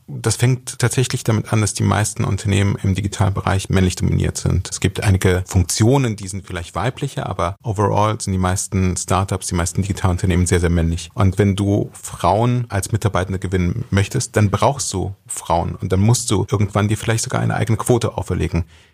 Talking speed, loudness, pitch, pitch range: 185 wpm, -19 LUFS, 100 Hz, 95-115 Hz